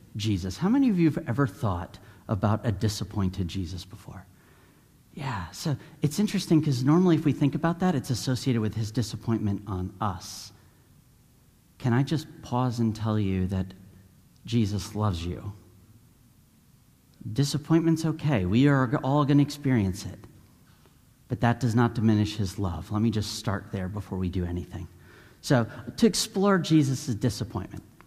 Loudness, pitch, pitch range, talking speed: -27 LUFS, 115 Hz, 100-140 Hz, 155 wpm